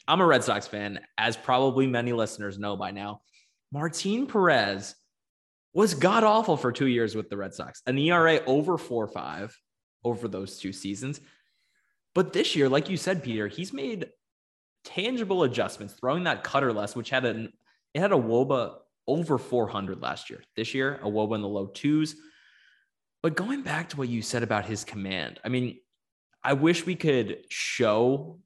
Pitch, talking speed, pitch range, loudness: 125 Hz, 180 wpm, 105-160 Hz, -27 LUFS